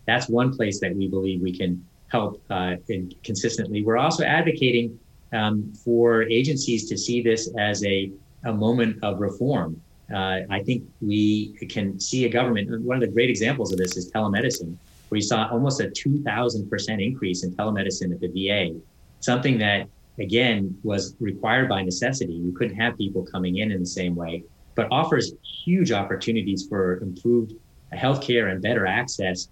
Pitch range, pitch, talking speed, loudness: 95-120 Hz, 105 Hz, 170 wpm, -24 LUFS